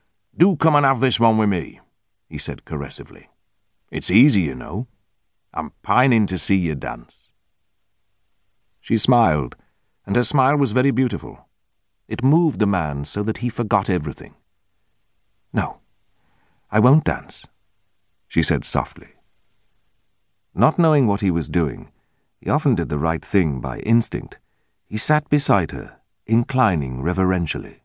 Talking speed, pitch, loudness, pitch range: 140 wpm, 100 Hz, -20 LUFS, 90-120 Hz